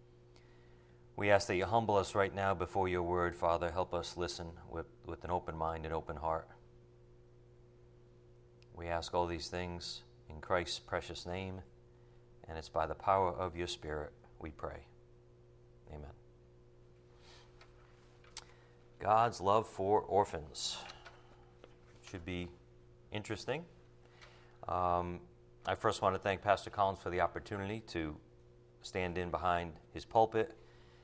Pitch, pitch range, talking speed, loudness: 80 Hz, 60-90 Hz, 130 wpm, -37 LUFS